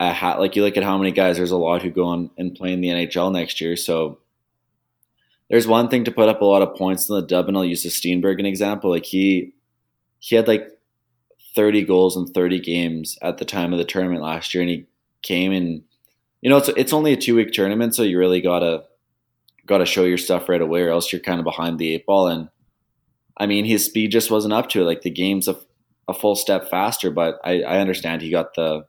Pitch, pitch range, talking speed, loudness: 90 Hz, 85-105 Hz, 250 wpm, -19 LUFS